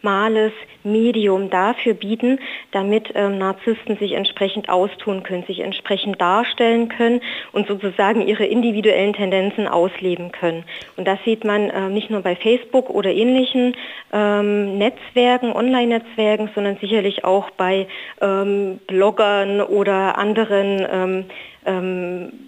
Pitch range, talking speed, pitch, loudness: 195-225 Hz, 125 wpm, 205 Hz, -19 LUFS